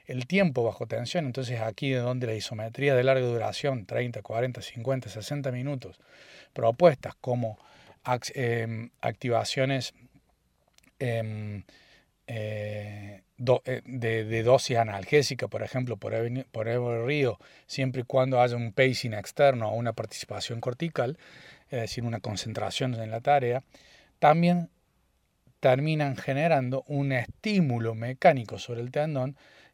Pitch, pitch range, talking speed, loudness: 125 Hz, 115-135 Hz, 115 wpm, -28 LUFS